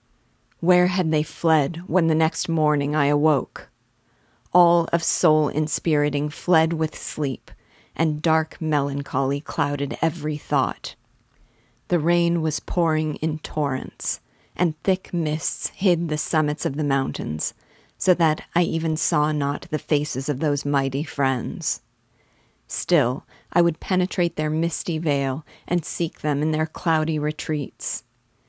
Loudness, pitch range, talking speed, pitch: -22 LUFS, 145-165 Hz, 135 wpm, 155 Hz